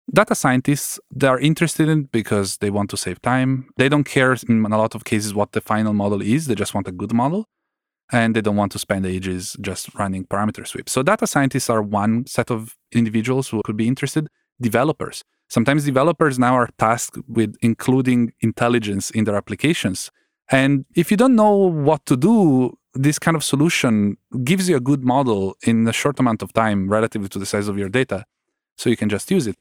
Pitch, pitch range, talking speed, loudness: 120 Hz, 105-145 Hz, 205 wpm, -19 LUFS